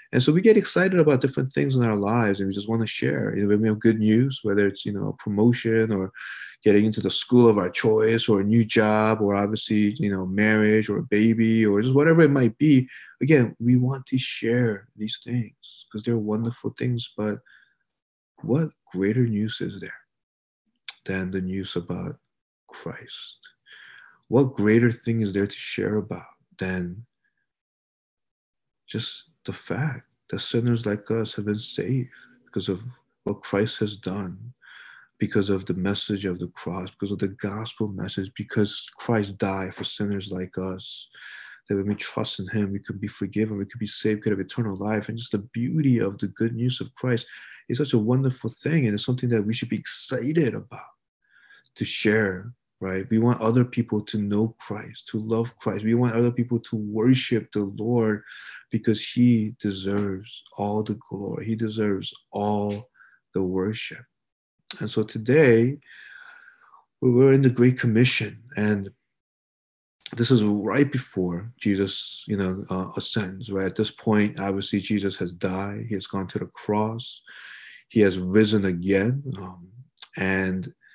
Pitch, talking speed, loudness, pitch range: 110 Hz, 175 wpm, -24 LUFS, 100-120 Hz